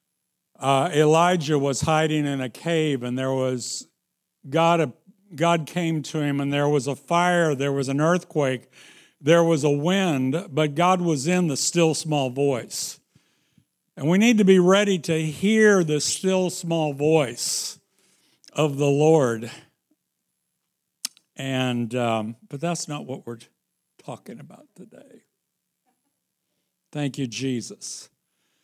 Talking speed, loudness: 135 wpm, -22 LUFS